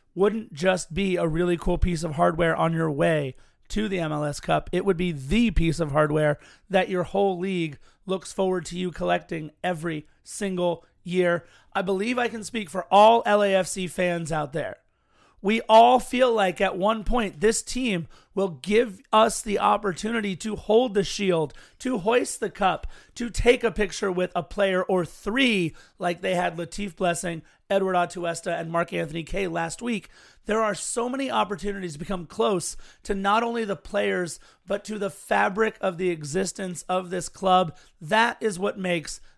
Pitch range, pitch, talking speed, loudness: 170-210 Hz, 190 Hz, 180 wpm, -25 LUFS